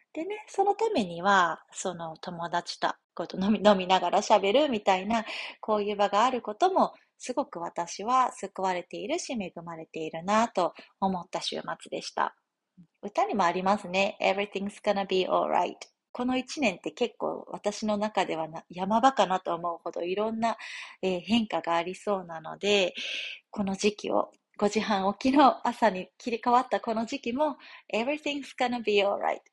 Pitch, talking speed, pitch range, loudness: 205 Hz, 380 characters per minute, 185-245 Hz, -28 LUFS